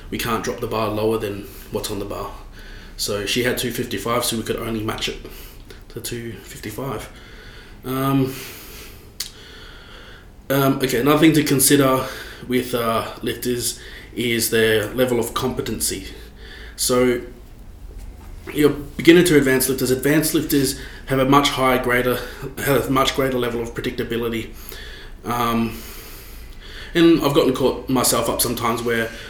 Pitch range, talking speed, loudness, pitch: 115-135 Hz, 135 wpm, -20 LUFS, 120 Hz